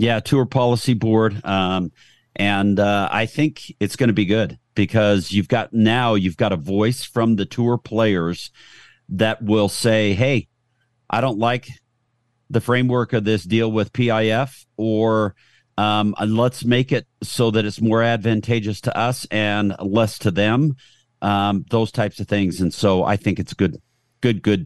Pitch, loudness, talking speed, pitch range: 110 Hz, -20 LUFS, 170 wpm, 105-120 Hz